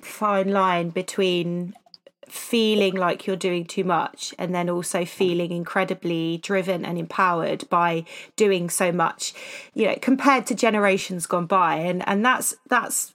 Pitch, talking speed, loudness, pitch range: 185 Hz, 145 wpm, -23 LUFS, 175-200 Hz